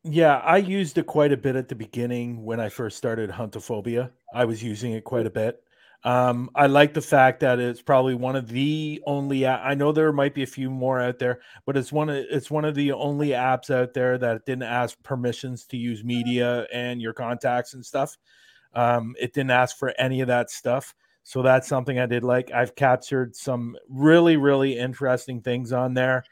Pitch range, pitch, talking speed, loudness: 120-140 Hz, 125 Hz, 210 wpm, -23 LUFS